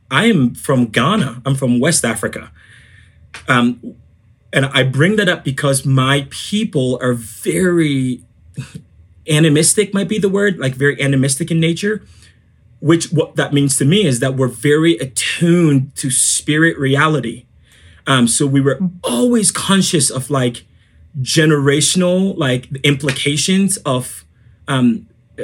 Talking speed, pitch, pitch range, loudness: 130 wpm, 140 Hz, 125-165 Hz, -15 LUFS